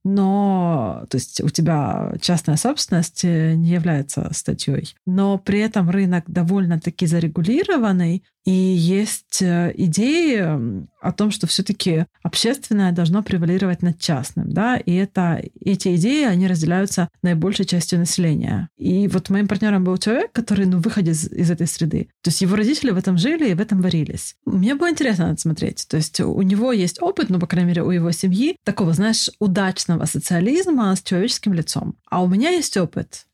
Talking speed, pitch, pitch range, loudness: 165 wpm, 185 Hz, 170-205 Hz, -19 LUFS